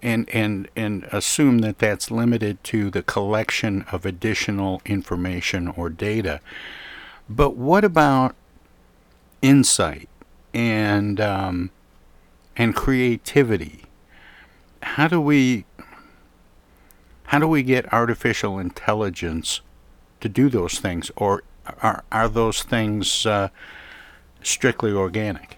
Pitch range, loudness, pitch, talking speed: 90-115 Hz, -21 LUFS, 105 Hz, 105 wpm